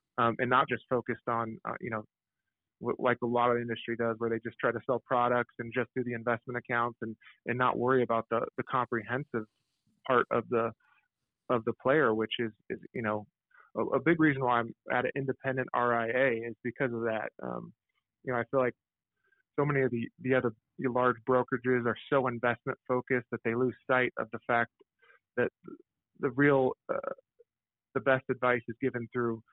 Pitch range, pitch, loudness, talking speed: 115-130 Hz, 120 Hz, -31 LUFS, 200 wpm